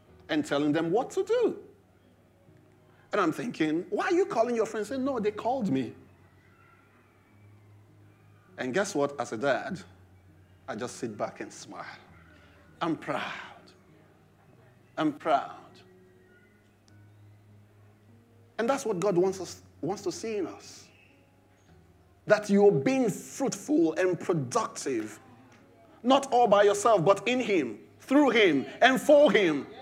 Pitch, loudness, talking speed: 135 Hz, -27 LUFS, 130 wpm